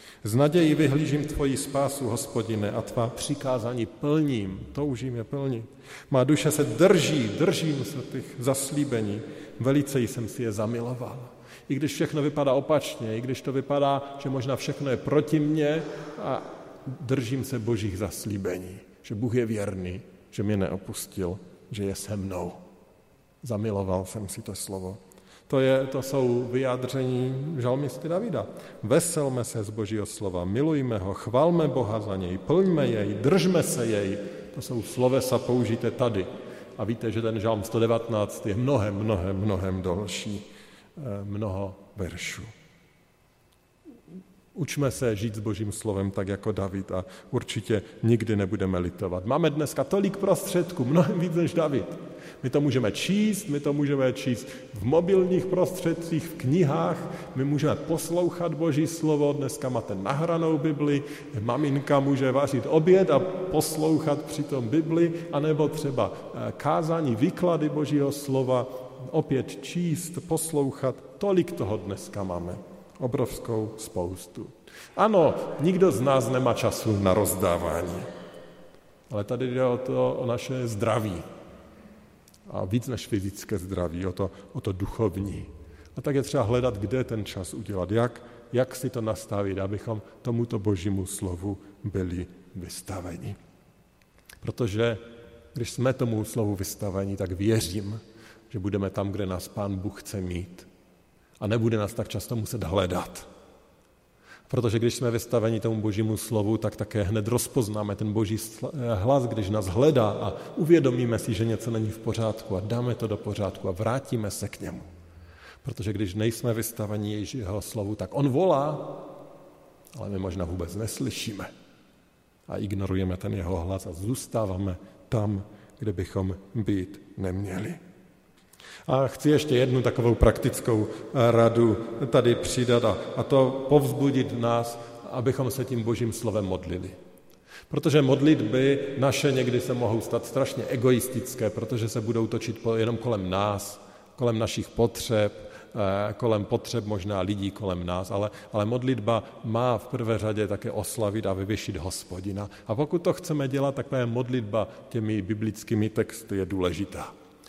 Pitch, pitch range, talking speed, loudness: 115 Hz, 100-135 Hz, 140 wpm, -27 LUFS